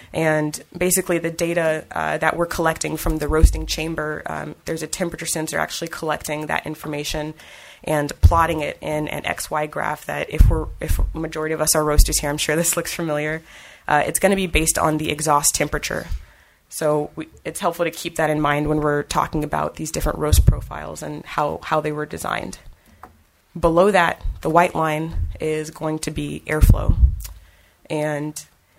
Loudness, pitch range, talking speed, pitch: -21 LUFS, 145-160 Hz, 185 wpm, 155 Hz